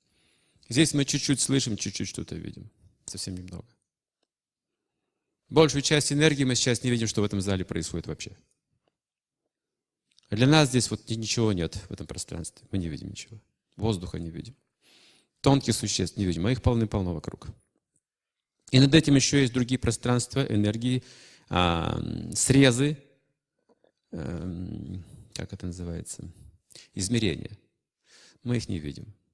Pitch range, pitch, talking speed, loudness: 95-130 Hz, 110 Hz, 135 wpm, -26 LUFS